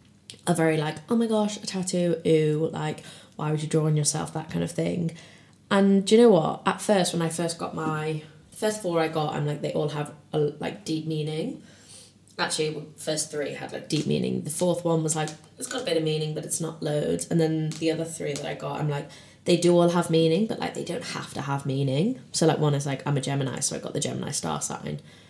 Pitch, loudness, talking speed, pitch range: 155 Hz, -26 LUFS, 250 wpm, 150-170 Hz